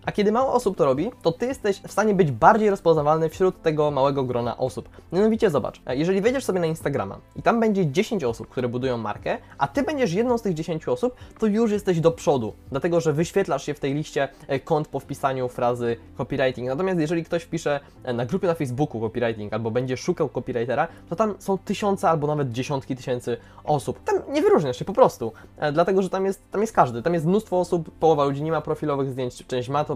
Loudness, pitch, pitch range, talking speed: -24 LUFS, 160 Hz, 130-195 Hz, 215 wpm